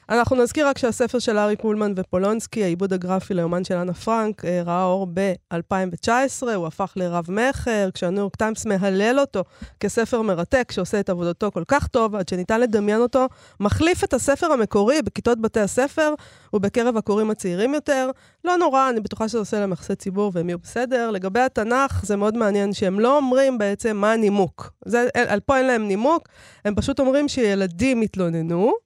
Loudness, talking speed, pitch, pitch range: -21 LUFS, 175 wpm, 215 Hz, 195-250 Hz